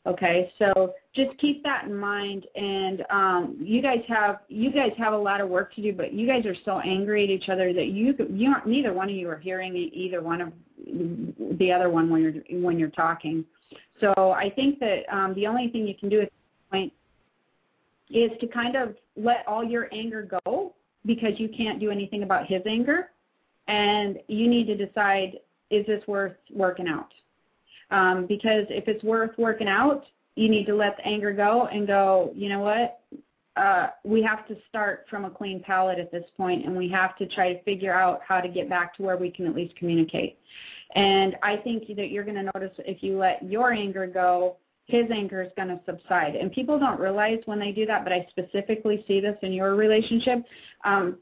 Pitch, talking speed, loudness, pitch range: 200 Hz, 210 wpm, -25 LUFS, 185-220 Hz